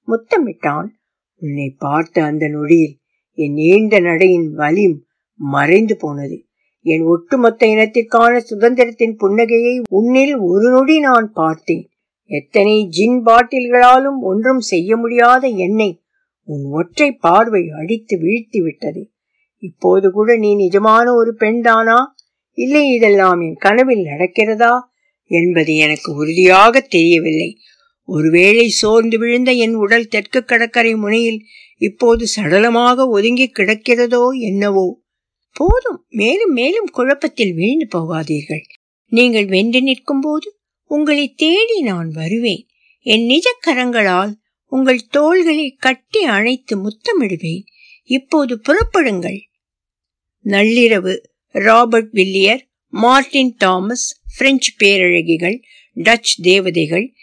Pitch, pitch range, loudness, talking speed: 225 Hz, 185-255 Hz, -13 LUFS, 85 wpm